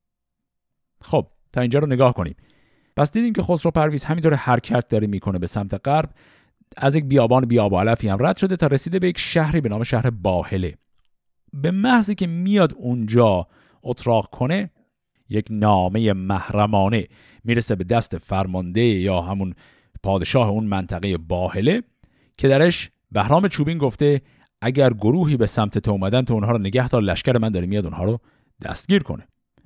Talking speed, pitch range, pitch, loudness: 160 wpm, 100-145 Hz, 120 Hz, -20 LUFS